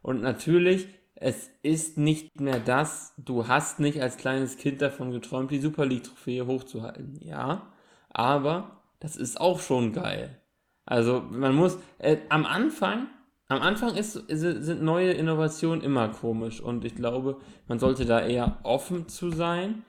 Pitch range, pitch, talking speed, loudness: 130-175 Hz, 150 Hz, 155 wpm, -27 LUFS